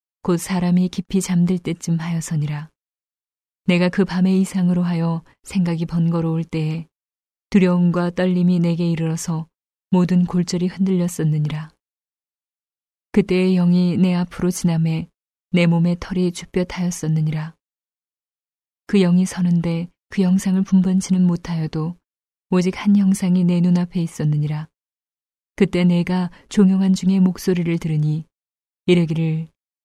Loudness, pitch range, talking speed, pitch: -19 LUFS, 165-185 Hz, 275 characters per minute, 175 Hz